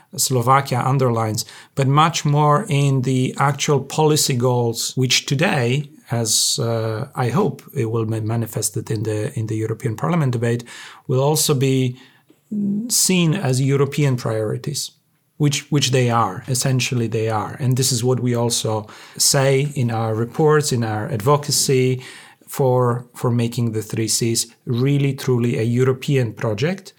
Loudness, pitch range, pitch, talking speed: -19 LUFS, 115-145 Hz, 130 Hz, 145 wpm